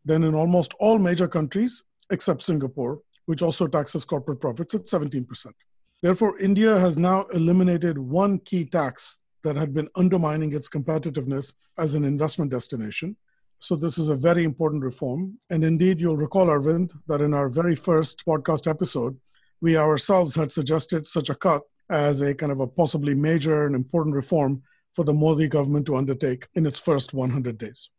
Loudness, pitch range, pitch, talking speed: -23 LUFS, 145-175 Hz, 160 Hz, 170 wpm